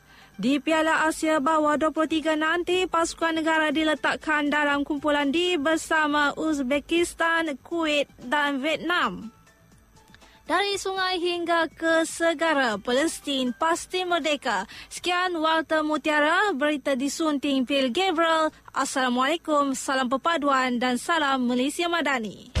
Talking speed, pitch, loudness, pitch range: 105 wpm, 310 Hz, -24 LUFS, 280-330 Hz